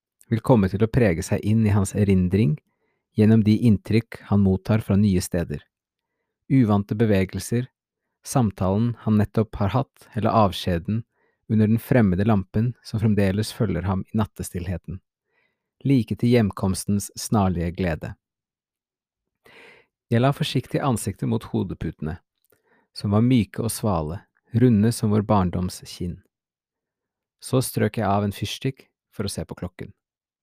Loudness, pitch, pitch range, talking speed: -23 LUFS, 105 Hz, 95-115 Hz, 135 wpm